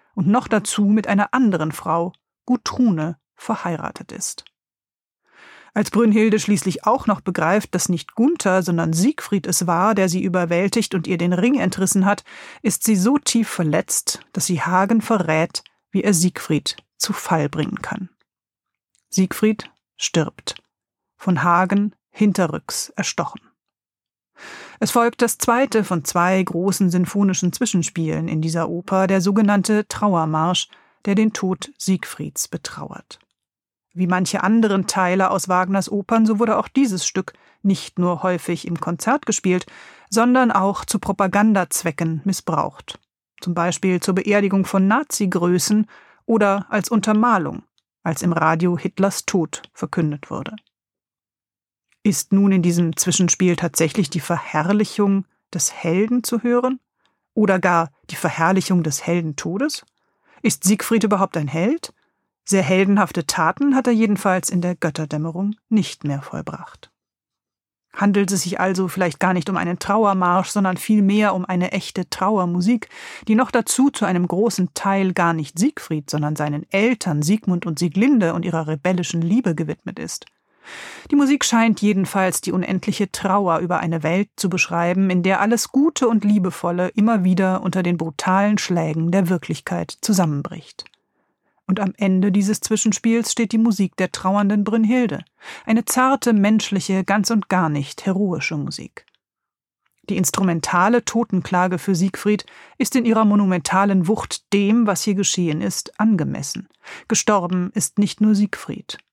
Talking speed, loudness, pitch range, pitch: 140 wpm, -19 LUFS, 180-215 Hz, 190 Hz